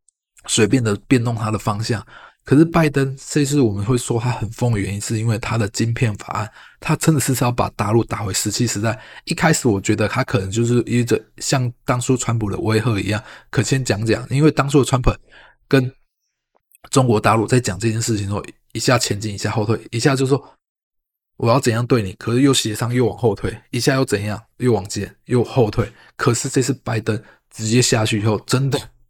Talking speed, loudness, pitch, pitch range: 305 characters per minute, -19 LUFS, 120 Hz, 110-130 Hz